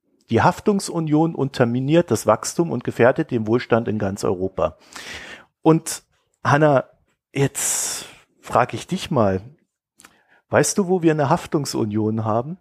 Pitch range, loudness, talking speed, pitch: 115-165 Hz, -20 LUFS, 125 wpm, 135 Hz